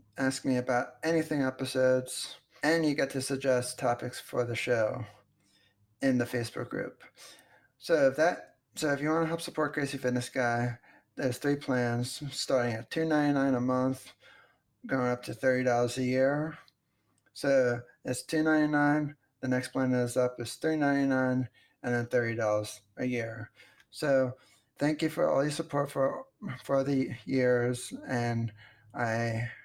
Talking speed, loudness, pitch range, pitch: 150 wpm, -30 LUFS, 120-140 Hz, 130 Hz